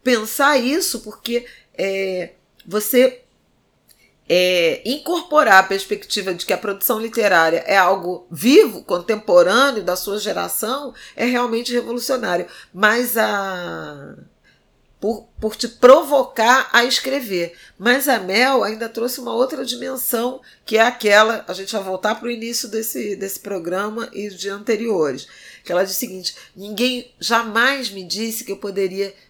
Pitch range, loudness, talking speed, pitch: 195-245 Hz, -18 LUFS, 140 wpm, 220 Hz